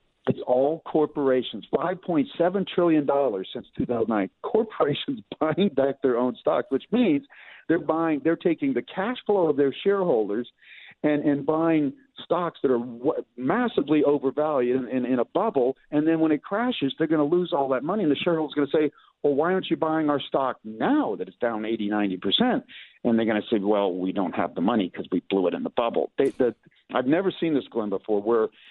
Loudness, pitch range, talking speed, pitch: -25 LUFS, 130-170 Hz, 210 wpm, 150 Hz